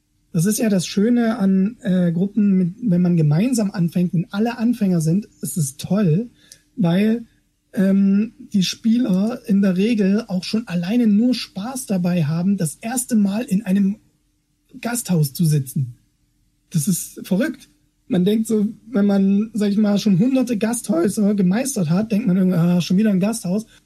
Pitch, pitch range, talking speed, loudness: 200 Hz, 185-225 Hz, 165 wpm, -19 LUFS